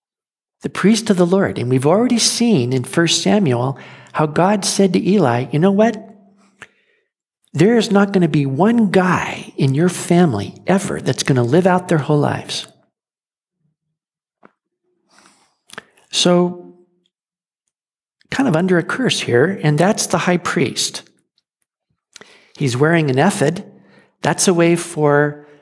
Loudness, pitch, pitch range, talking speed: -16 LUFS, 180 Hz, 150-200 Hz, 140 wpm